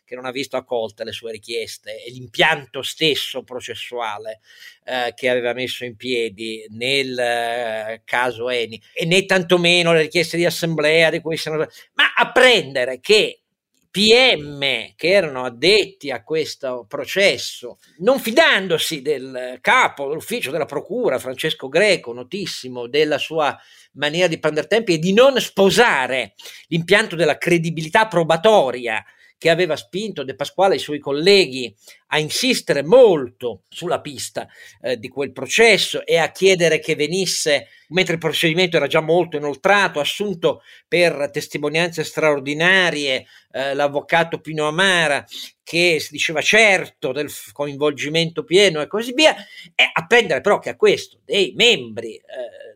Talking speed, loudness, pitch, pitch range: 140 wpm, -18 LUFS, 165 Hz, 140-200 Hz